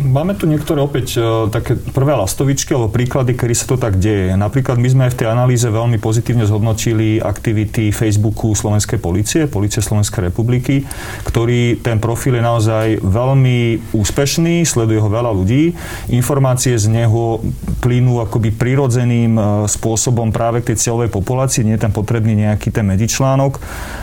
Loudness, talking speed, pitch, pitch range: -15 LUFS, 150 wpm, 115 Hz, 110-125 Hz